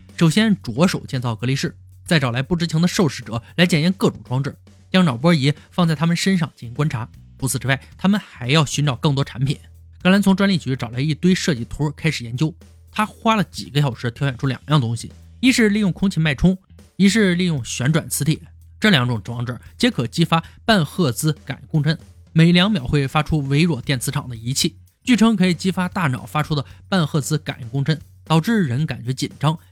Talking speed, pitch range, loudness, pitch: 315 characters per minute, 125-175 Hz, -20 LUFS, 150 Hz